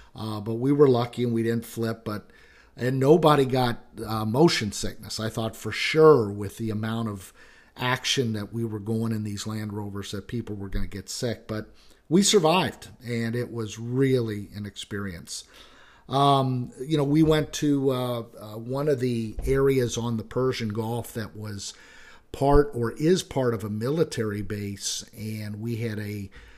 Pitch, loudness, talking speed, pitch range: 115 Hz, -25 LUFS, 180 wpm, 105-130 Hz